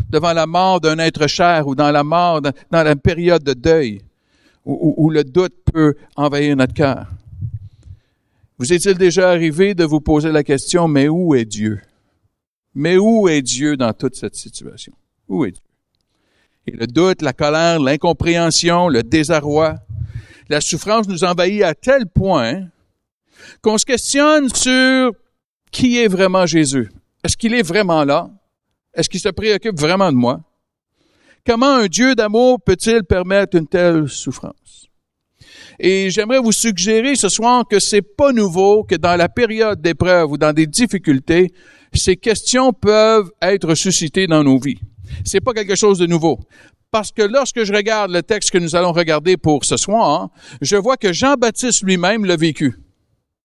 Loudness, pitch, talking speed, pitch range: -15 LUFS, 170 Hz, 165 wpm, 145-210 Hz